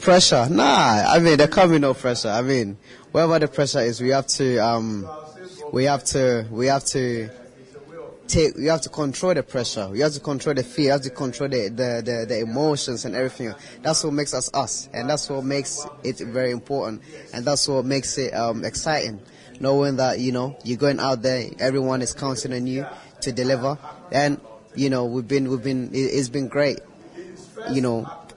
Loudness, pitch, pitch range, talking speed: -22 LUFS, 135 Hz, 125-145 Hz, 200 wpm